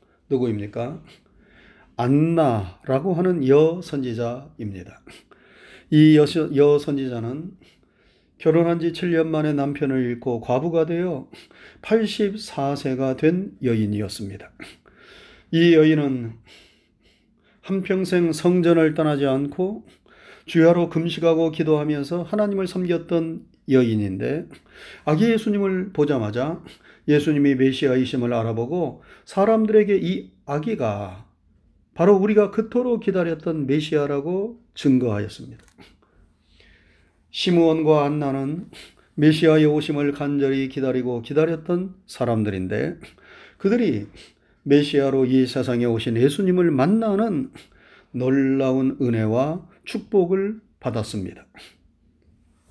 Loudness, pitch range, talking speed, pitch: -21 LUFS, 120-170 Hz, 240 characters per minute, 145 Hz